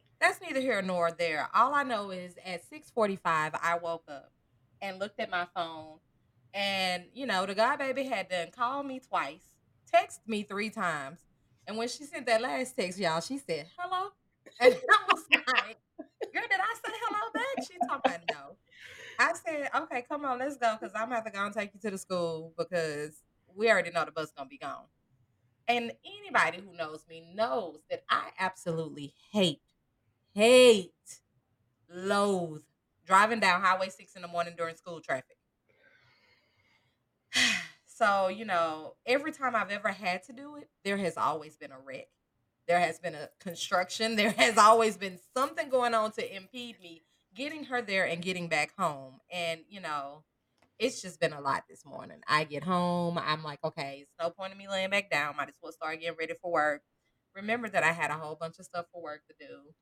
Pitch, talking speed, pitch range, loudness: 185 Hz, 195 wpm, 165-235 Hz, -30 LUFS